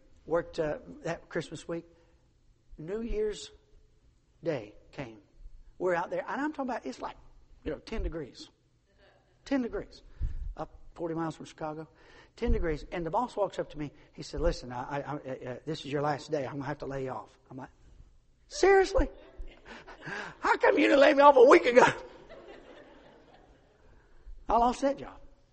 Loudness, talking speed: -29 LUFS, 175 wpm